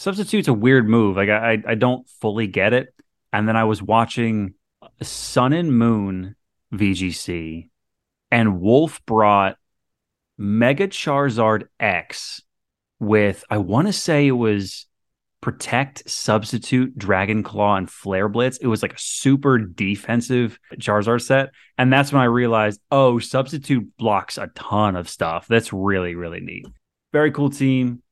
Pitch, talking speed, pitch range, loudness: 115 Hz, 145 wpm, 105-130 Hz, -19 LUFS